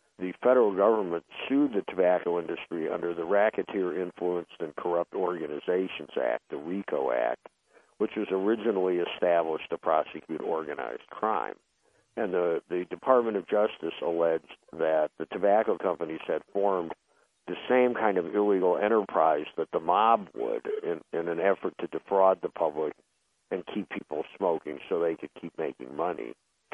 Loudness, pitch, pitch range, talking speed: -29 LUFS, 95 Hz, 85-115 Hz, 150 wpm